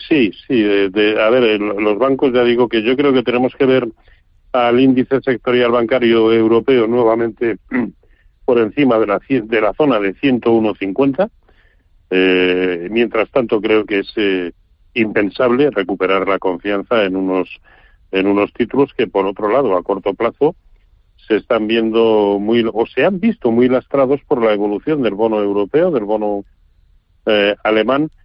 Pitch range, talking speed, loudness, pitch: 100-125 Hz, 160 wpm, -15 LUFS, 110 Hz